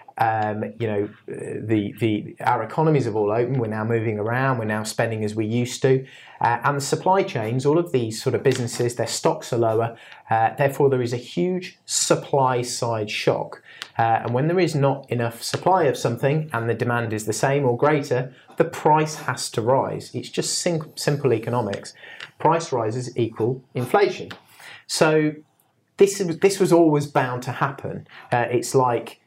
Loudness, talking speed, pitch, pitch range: -22 LUFS, 180 wpm, 125 Hz, 115-145 Hz